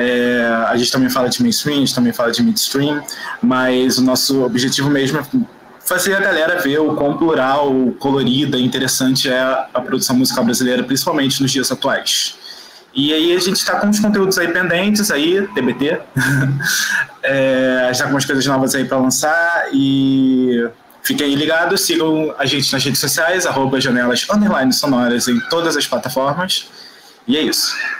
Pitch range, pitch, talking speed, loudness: 130-170 Hz, 135 Hz, 170 wpm, -15 LUFS